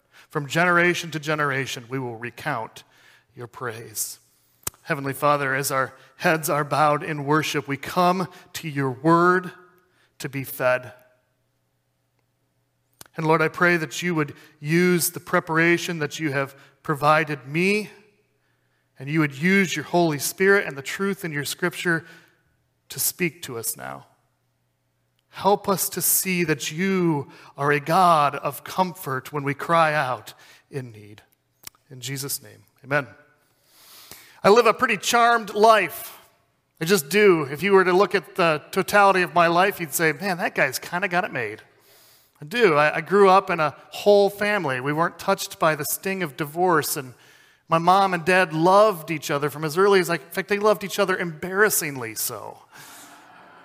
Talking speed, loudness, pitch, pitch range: 165 wpm, -22 LUFS, 160 Hz, 140-185 Hz